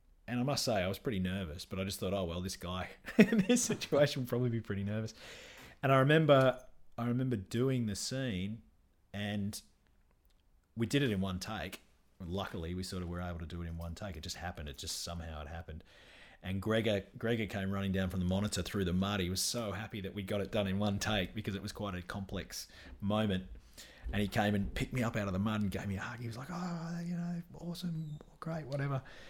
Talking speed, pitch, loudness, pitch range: 235 wpm, 100 Hz, -35 LUFS, 95-125 Hz